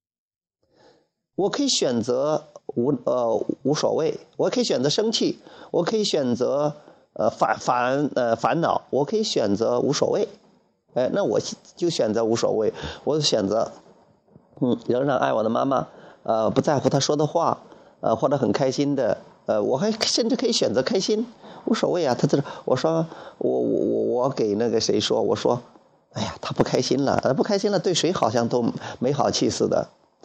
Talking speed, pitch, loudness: 245 characters per minute, 205 Hz, -23 LUFS